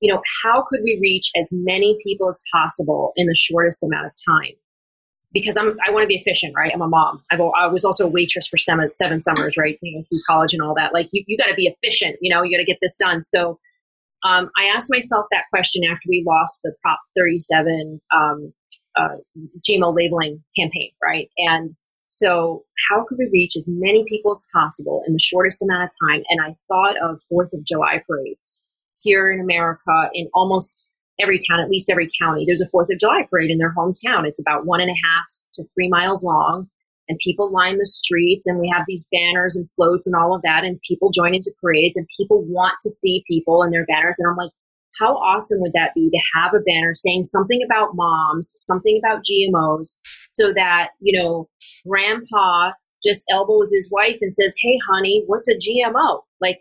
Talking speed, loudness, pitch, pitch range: 210 wpm, -18 LUFS, 180 Hz, 170-200 Hz